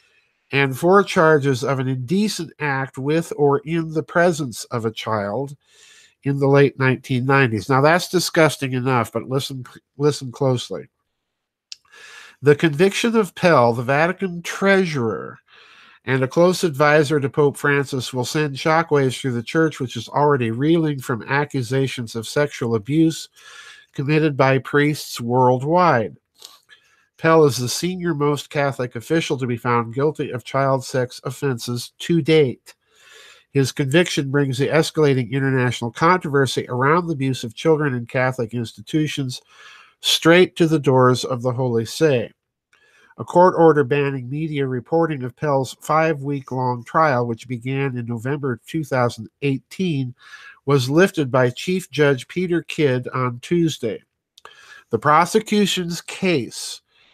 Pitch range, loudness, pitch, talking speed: 130-160 Hz, -19 LUFS, 140 Hz, 135 wpm